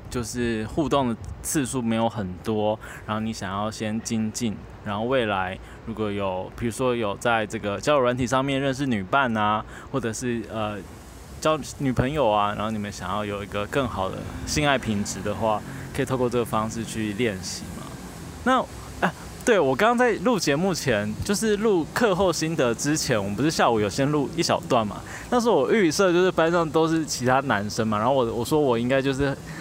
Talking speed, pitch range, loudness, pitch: 290 characters per minute, 105-140 Hz, -24 LUFS, 115 Hz